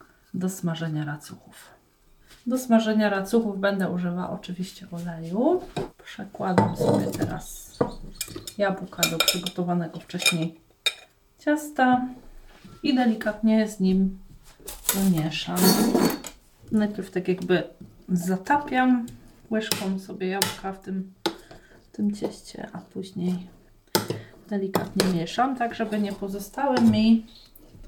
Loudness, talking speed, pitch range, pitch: -25 LUFS, 95 wpm, 180-220 Hz, 195 Hz